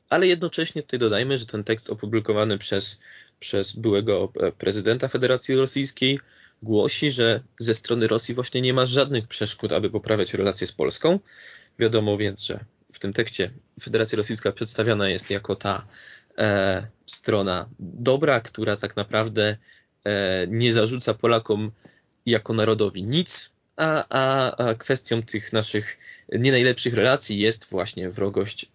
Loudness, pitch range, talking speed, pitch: -23 LUFS, 105-130 Hz, 140 wpm, 115 Hz